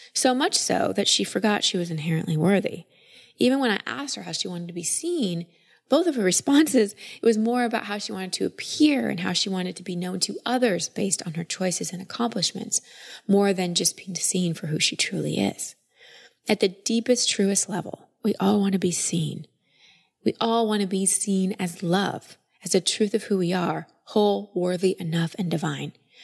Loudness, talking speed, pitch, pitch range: -24 LUFS, 205 wpm, 195 Hz, 180-225 Hz